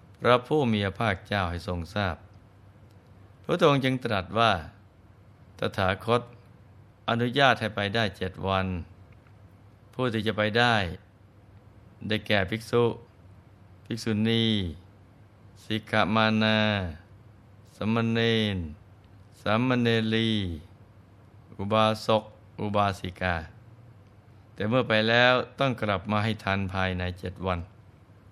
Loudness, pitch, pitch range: -26 LUFS, 105 Hz, 100-110 Hz